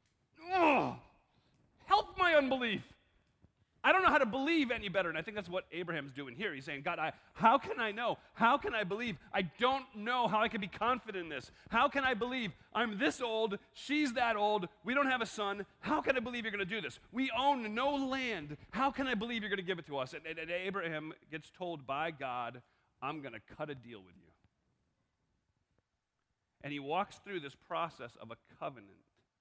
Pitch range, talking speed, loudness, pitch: 160-255 Hz, 215 wpm, -35 LUFS, 205 Hz